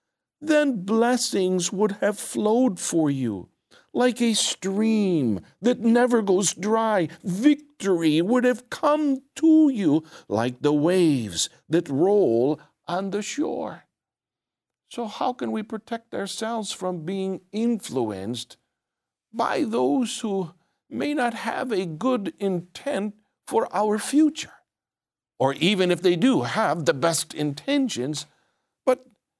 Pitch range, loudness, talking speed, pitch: 170-245 Hz, -24 LUFS, 120 wpm, 205 Hz